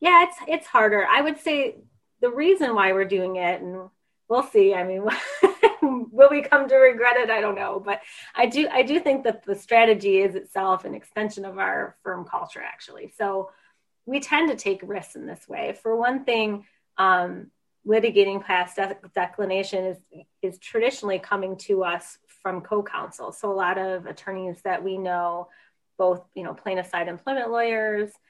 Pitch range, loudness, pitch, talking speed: 190-255 Hz, -23 LUFS, 205 Hz, 180 wpm